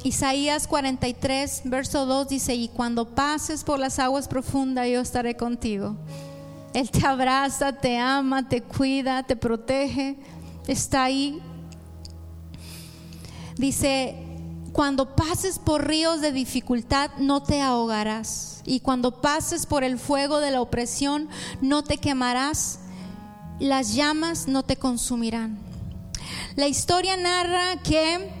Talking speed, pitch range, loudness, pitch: 120 wpm, 230-280 Hz, -24 LUFS, 265 Hz